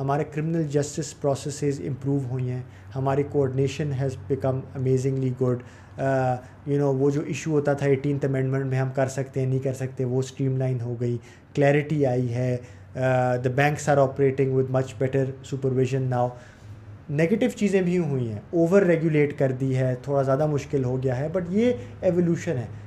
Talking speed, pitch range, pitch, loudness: 175 wpm, 130-145 Hz, 135 Hz, -25 LUFS